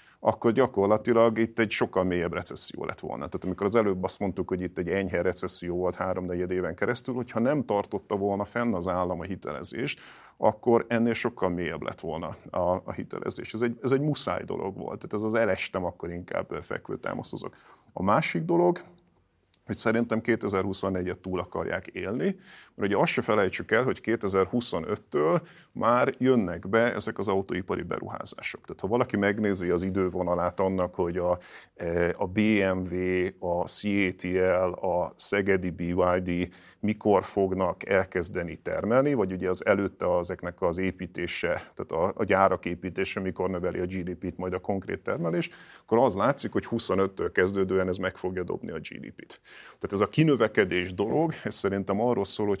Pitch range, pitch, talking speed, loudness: 90-110 Hz, 95 Hz, 160 wpm, -28 LUFS